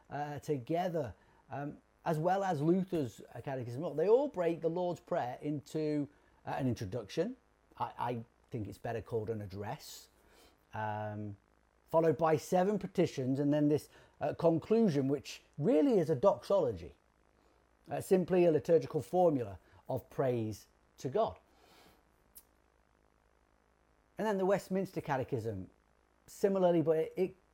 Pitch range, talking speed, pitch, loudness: 110-175 Hz, 130 wpm, 150 Hz, -34 LUFS